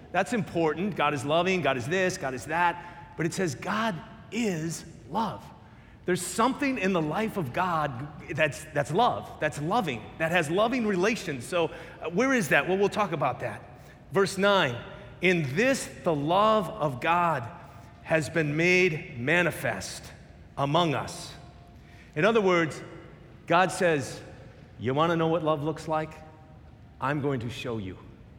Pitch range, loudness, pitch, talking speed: 145-185 Hz, -27 LUFS, 165 Hz, 155 wpm